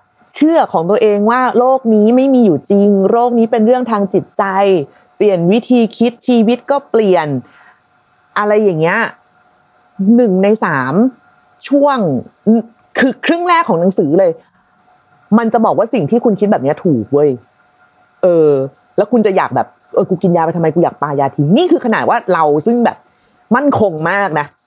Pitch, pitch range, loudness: 215 Hz, 185-240 Hz, -12 LUFS